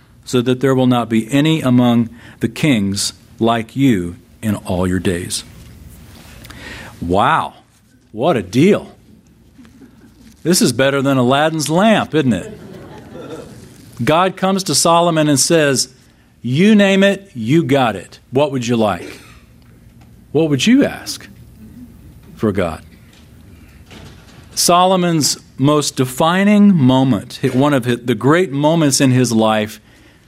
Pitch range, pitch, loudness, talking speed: 115-155 Hz, 130 Hz, -15 LUFS, 125 wpm